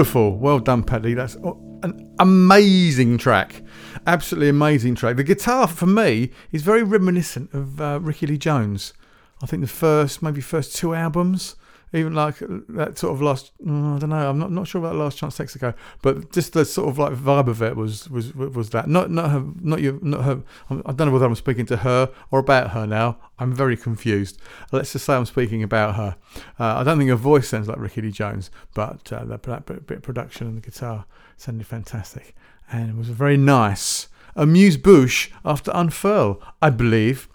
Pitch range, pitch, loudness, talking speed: 115-155 Hz, 135 Hz, -20 LUFS, 200 wpm